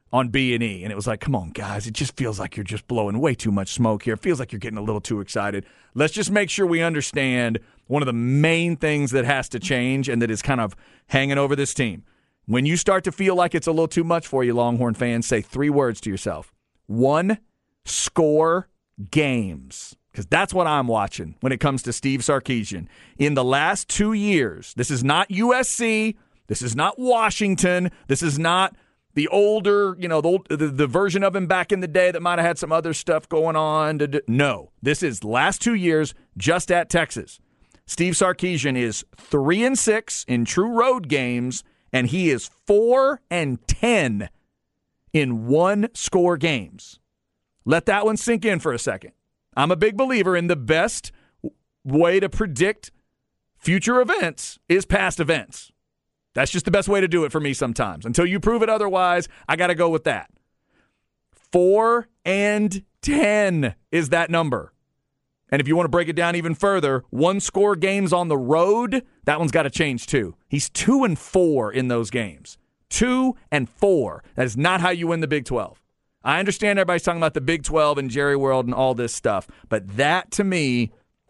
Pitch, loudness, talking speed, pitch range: 155 Hz, -21 LUFS, 200 wpm, 125-185 Hz